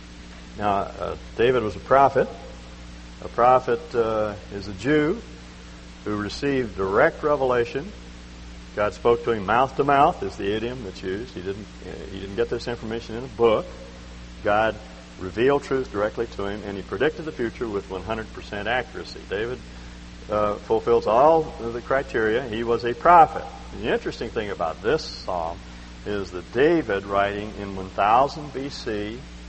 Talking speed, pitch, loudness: 160 wpm, 100 Hz, -23 LUFS